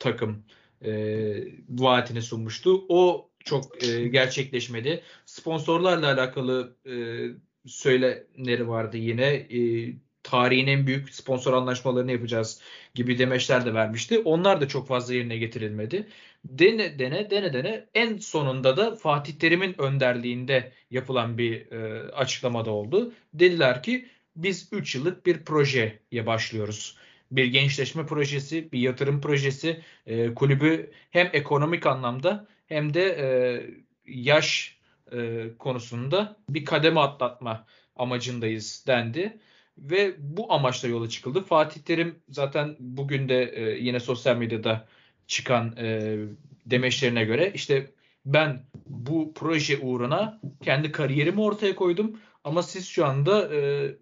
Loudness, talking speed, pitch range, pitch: -25 LUFS, 120 wpm, 120-160 Hz, 130 Hz